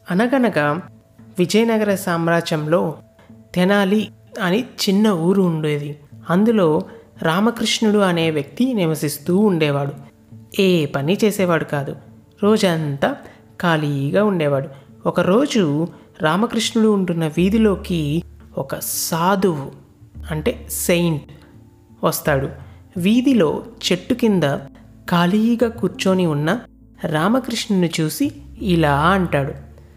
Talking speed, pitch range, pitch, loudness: 80 wpm, 145-205 Hz, 175 Hz, -19 LUFS